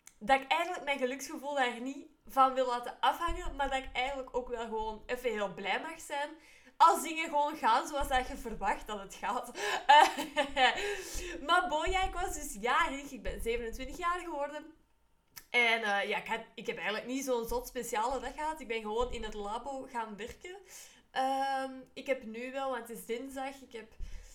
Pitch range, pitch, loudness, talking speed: 235-295 Hz, 260 Hz, -33 LUFS, 195 wpm